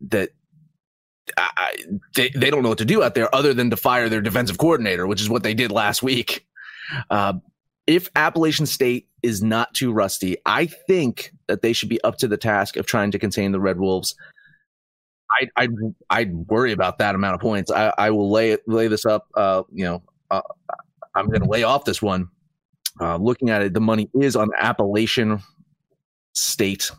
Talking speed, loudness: 195 wpm, -21 LUFS